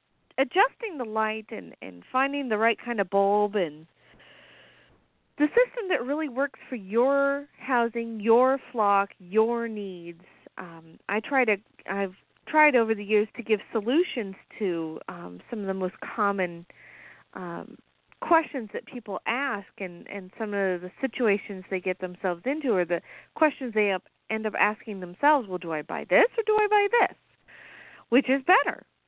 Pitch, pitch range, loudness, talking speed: 220 Hz, 195-270 Hz, -26 LUFS, 165 wpm